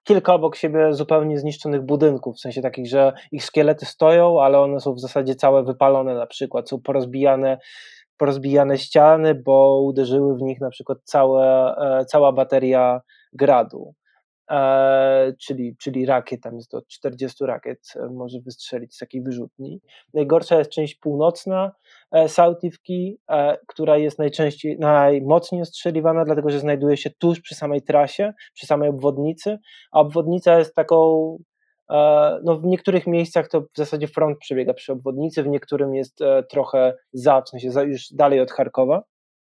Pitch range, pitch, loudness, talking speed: 135-160 Hz, 145 Hz, -19 LUFS, 155 wpm